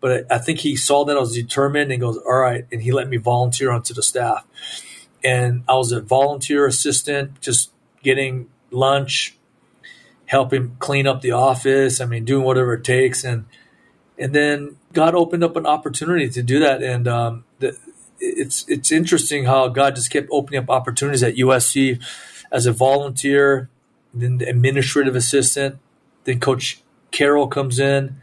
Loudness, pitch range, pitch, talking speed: -18 LUFS, 125-140 Hz, 135 Hz, 170 wpm